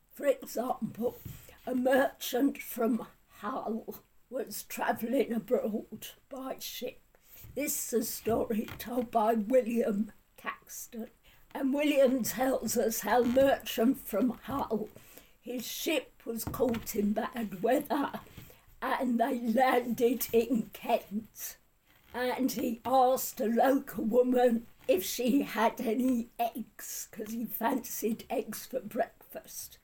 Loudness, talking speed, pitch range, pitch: -31 LUFS, 115 wpm, 225-255 Hz, 240 Hz